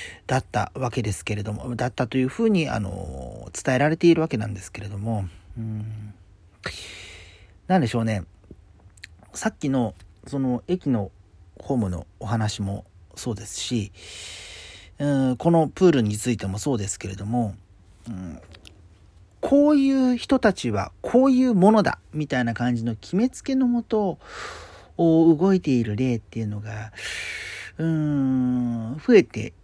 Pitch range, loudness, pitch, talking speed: 95-145 Hz, -23 LUFS, 115 Hz, 280 characters per minute